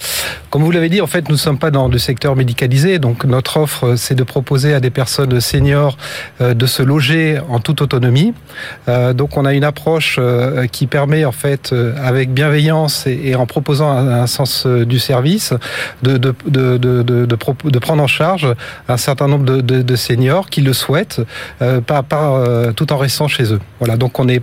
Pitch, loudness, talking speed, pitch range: 135 Hz, -14 LUFS, 175 wpm, 125-150 Hz